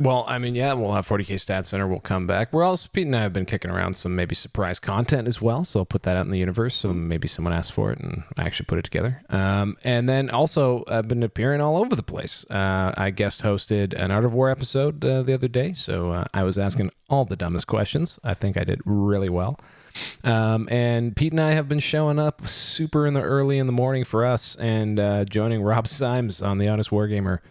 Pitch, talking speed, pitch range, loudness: 110 Hz, 245 wpm, 100-130 Hz, -23 LUFS